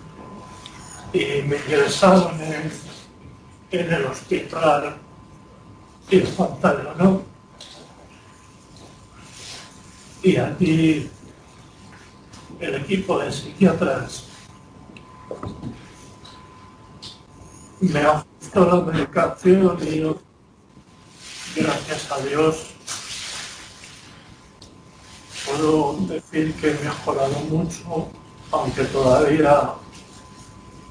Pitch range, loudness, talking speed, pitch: 145-170 Hz, -21 LUFS, 65 wpm, 155 Hz